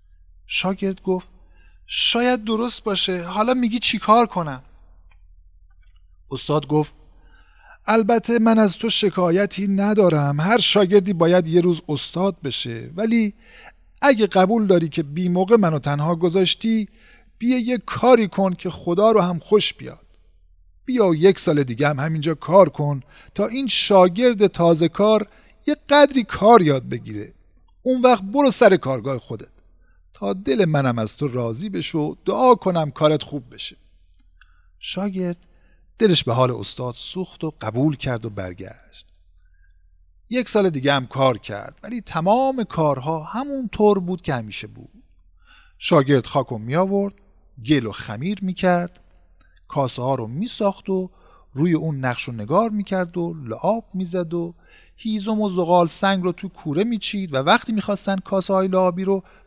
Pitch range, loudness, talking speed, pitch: 130-205 Hz, -19 LUFS, 150 wpm, 175 Hz